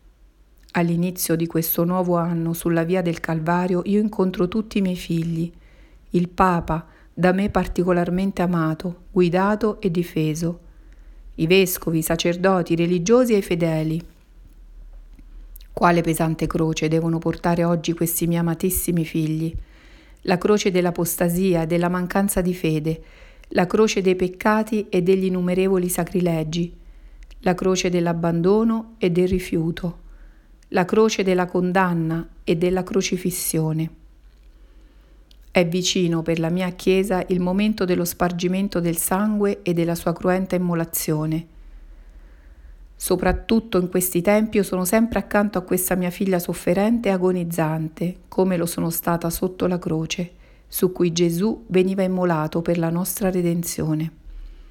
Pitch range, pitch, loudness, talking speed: 165-185 Hz, 175 Hz, -21 LUFS, 130 wpm